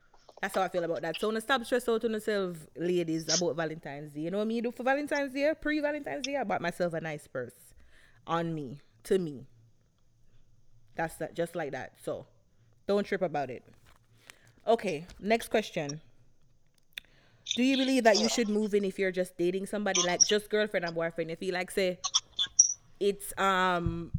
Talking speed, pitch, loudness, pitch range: 180 wpm, 180 Hz, -30 LUFS, 150-215 Hz